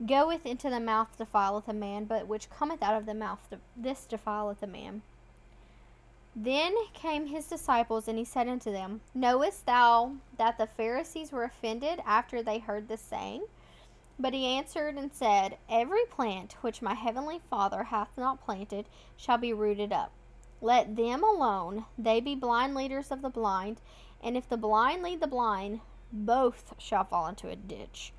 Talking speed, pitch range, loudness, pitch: 170 wpm, 215-265 Hz, -31 LUFS, 235 Hz